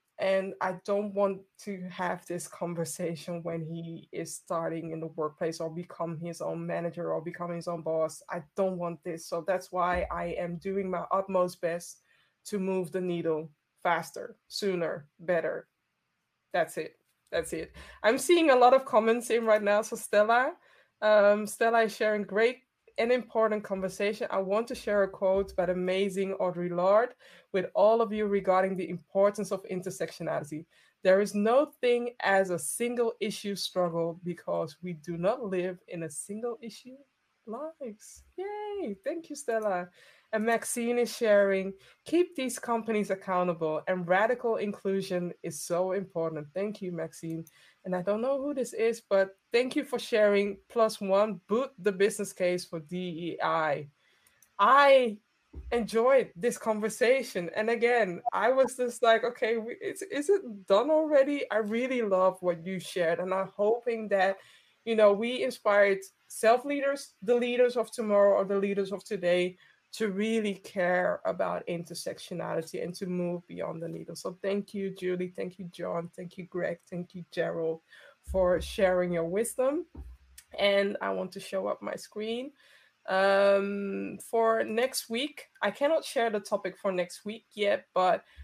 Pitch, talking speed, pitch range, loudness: 200 Hz, 160 wpm, 180-230 Hz, -29 LUFS